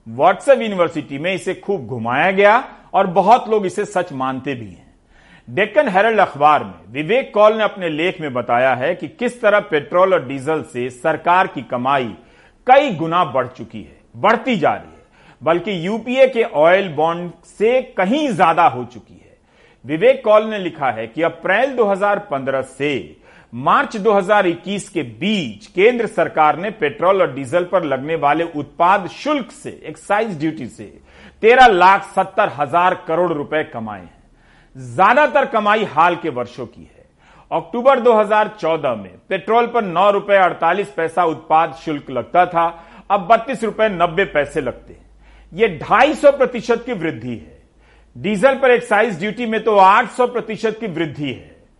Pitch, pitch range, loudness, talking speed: 185 Hz, 155-215 Hz, -16 LUFS, 160 wpm